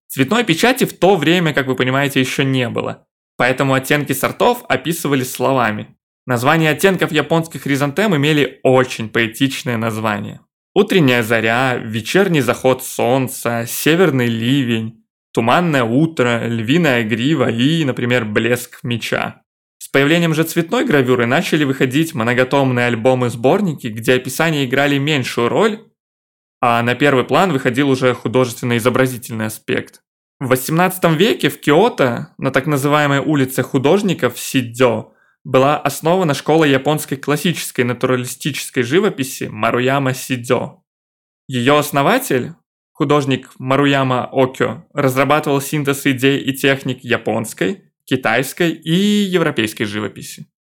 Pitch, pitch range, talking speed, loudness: 135 Hz, 125-150 Hz, 115 wpm, -16 LUFS